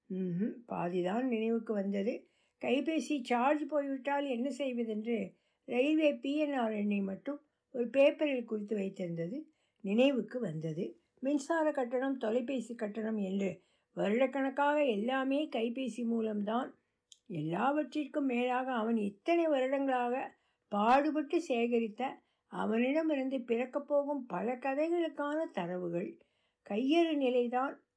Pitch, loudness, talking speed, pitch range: 255 Hz, -34 LUFS, 90 wpm, 220-285 Hz